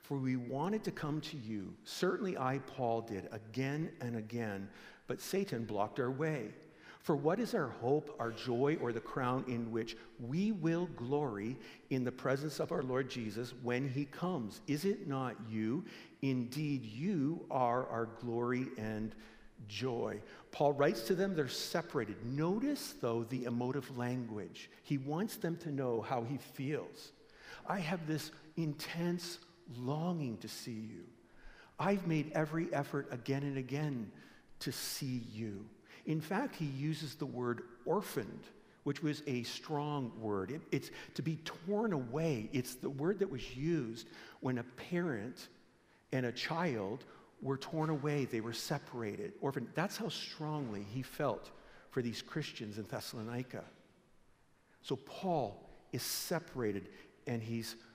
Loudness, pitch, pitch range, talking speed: -39 LUFS, 135 Hz, 115-155 Hz, 150 wpm